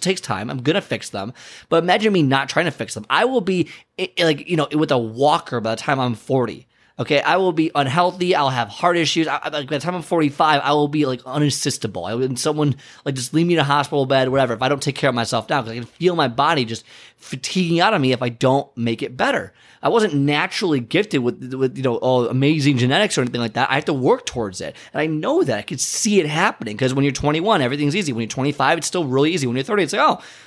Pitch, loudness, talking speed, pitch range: 140 Hz, -19 LUFS, 265 wpm, 130-160 Hz